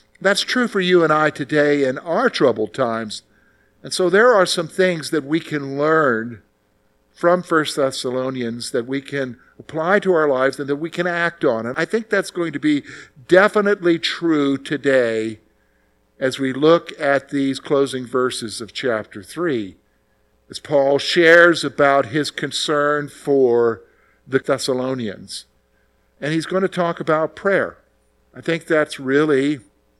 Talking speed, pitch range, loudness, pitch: 155 wpm, 125-165 Hz, -18 LUFS, 145 Hz